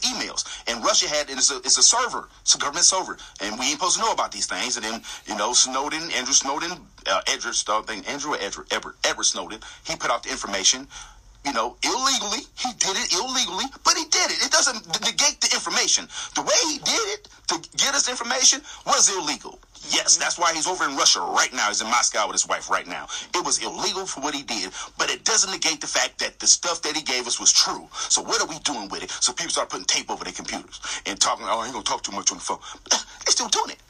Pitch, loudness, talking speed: 235 Hz, -21 LUFS, 250 wpm